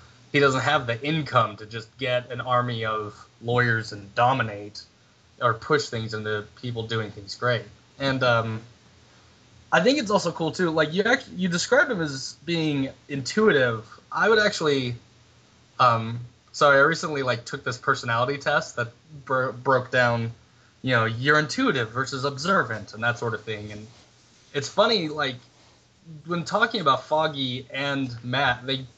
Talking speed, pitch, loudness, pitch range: 160 wpm, 125 Hz, -24 LUFS, 115-150 Hz